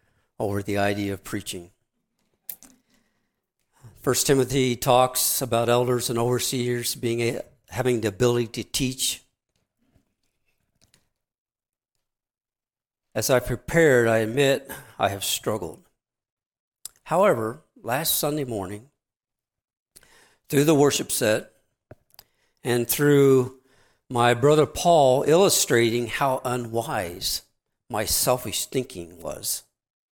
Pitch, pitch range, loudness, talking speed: 125 Hz, 115-135 Hz, -23 LUFS, 95 wpm